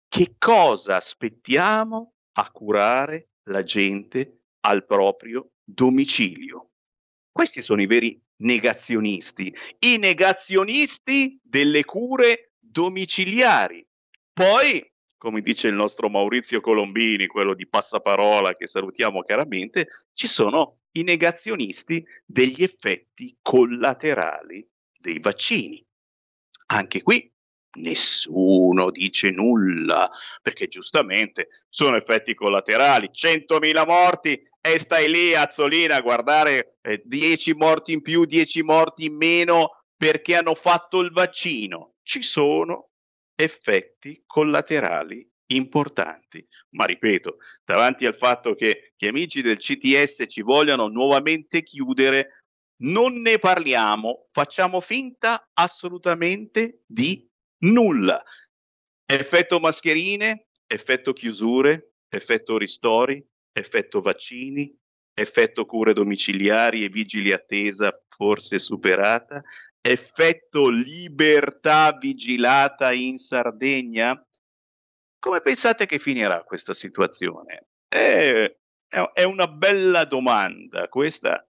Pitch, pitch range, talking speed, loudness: 160 Hz, 125-210 Hz, 100 wpm, -20 LUFS